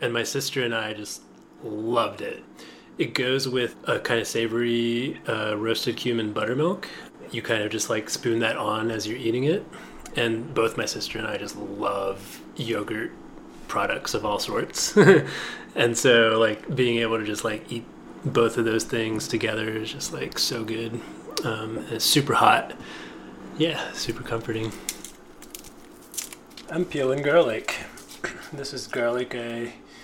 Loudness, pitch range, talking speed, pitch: -25 LUFS, 110-120 Hz, 155 wpm, 115 Hz